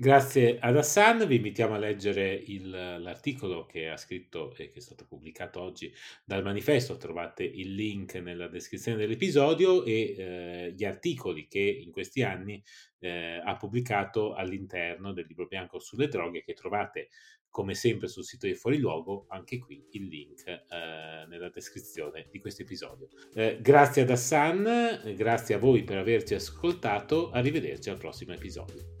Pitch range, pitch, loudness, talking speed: 95-140 Hz, 105 Hz, -29 LUFS, 155 wpm